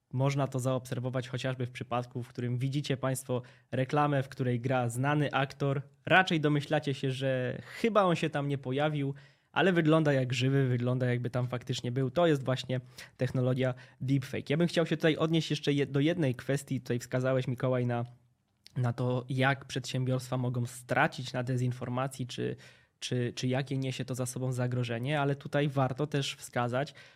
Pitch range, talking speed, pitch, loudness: 125-140 Hz, 170 wpm, 130 Hz, -31 LUFS